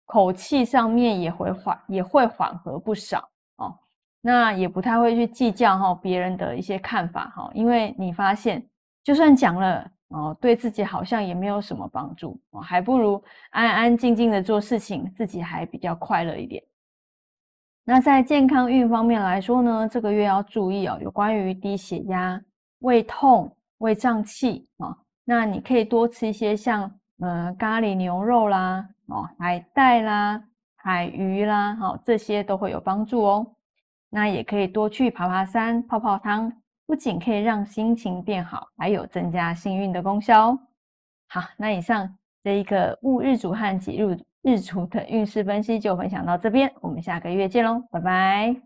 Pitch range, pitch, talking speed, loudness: 190-235 Hz, 210 Hz, 250 characters per minute, -23 LUFS